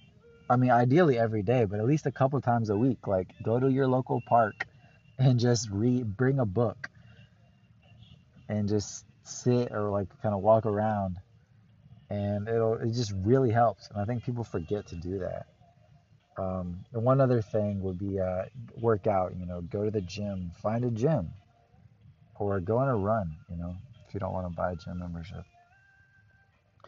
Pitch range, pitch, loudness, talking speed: 100-125 Hz, 110 Hz, -29 LUFS, 190 wpm